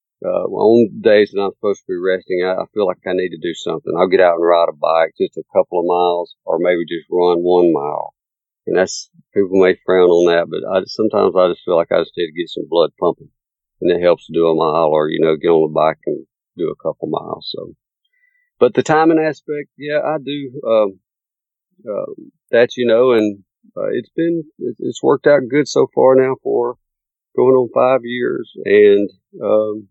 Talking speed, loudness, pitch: 220 wpm, -16 LUFS, 120 Hz